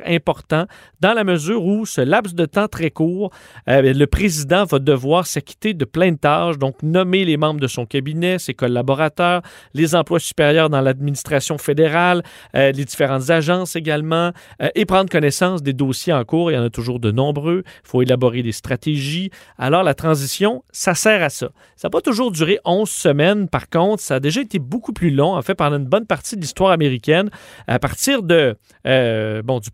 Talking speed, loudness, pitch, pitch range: 200 wpm, -18 LUFS, 160 Hz, 135-185 Hz